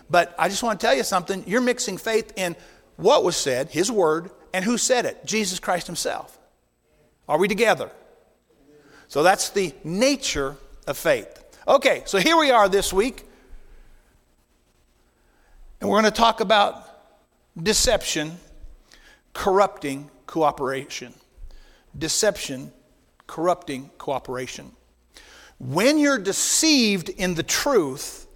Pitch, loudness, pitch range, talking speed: 185 Hz, -22 LUFS, 145-215 Hz, 125 wpm